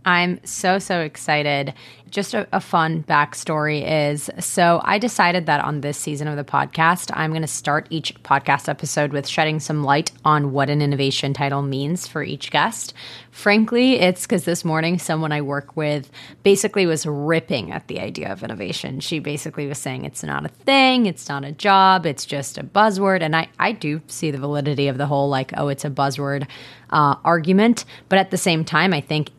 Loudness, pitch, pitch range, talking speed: -20 LUFS, 155 Hz, 140-175 Hz, 200 wpm